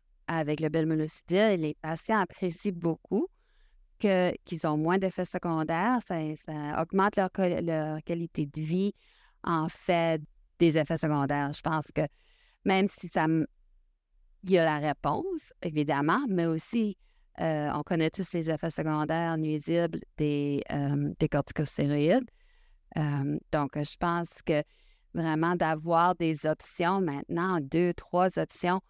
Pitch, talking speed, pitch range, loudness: 165 Hz, 135 wpm, 155-180 Hz, -29 LUFS